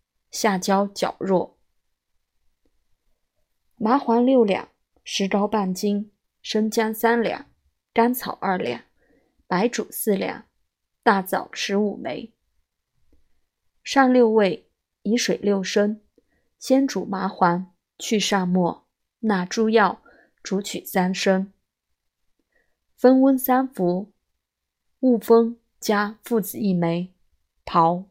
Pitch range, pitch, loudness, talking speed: 185-230 Hz, 205 Hz, -22 LUFS, 130 characters per minute